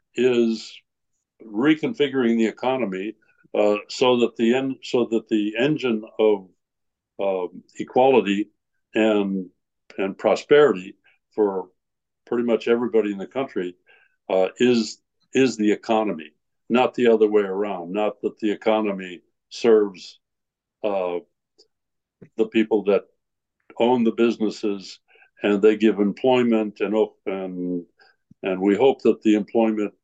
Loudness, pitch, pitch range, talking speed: -22 LUFS, 110 Hz, 100-115 Hz, 120 wpm